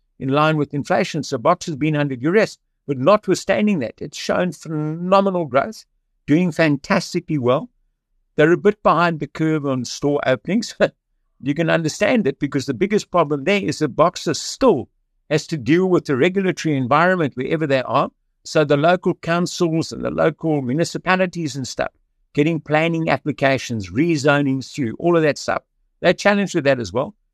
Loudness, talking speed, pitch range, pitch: -19 LUFS, 170 wpm, 145-175 Hz, 155 Hz